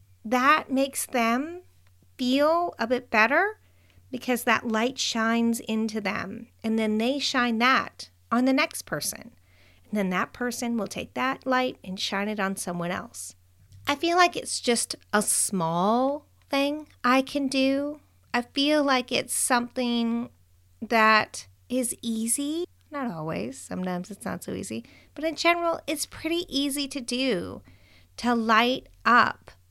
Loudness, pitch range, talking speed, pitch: -25 LUFS, 190-270 Hz, 145 wpm, 235 Hz